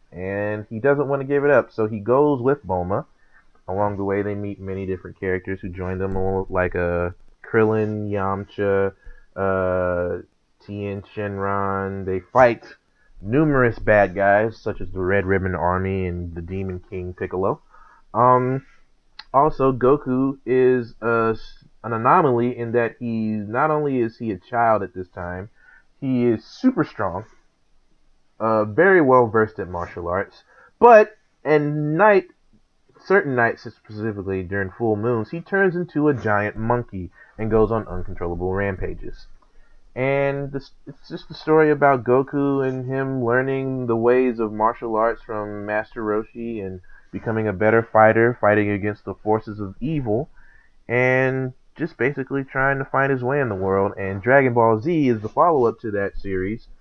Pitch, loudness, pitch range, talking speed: 110 Hz, -21 LUFS, 100-130 Hz, 155 wpm